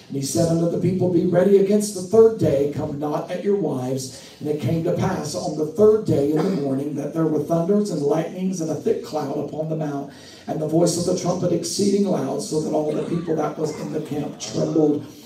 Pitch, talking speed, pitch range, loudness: 160 Hz, 240 wpm, 150-180 Hz, -21 LUFS